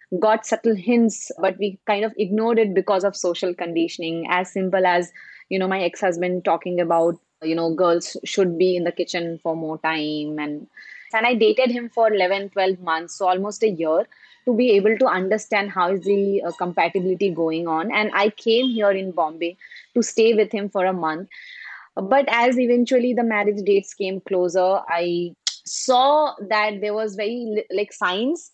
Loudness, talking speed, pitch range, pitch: -21 LUFS, 185 wpm, 175-220 Hz, 195 Hz